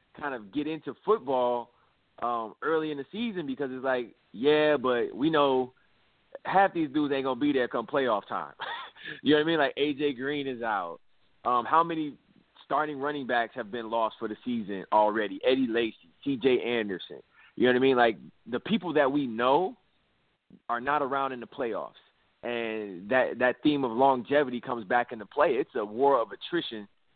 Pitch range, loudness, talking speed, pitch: 120-150 Hz, -28 LUFS, 190 wpm, 130 Hz